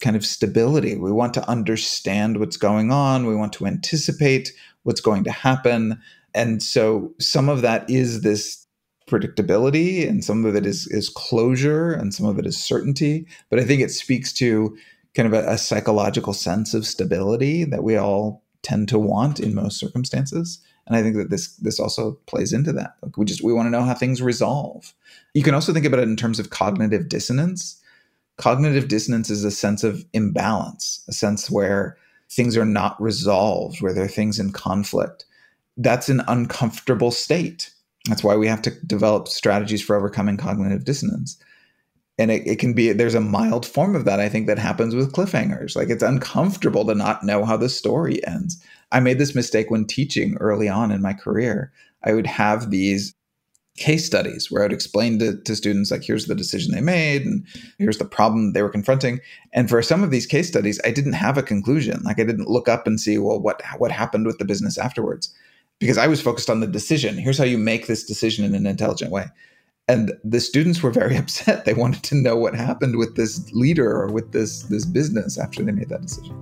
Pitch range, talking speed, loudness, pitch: 105-135 Hz, 205 wpm, -21 LUFS, 115 Hz